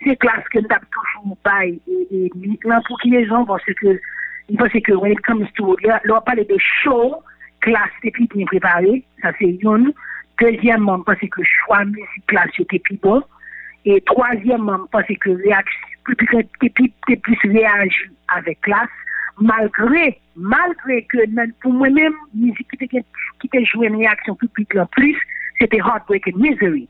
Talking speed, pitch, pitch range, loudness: 155 wpm, 225 Hz, 200-250 Hz, -16 LUFS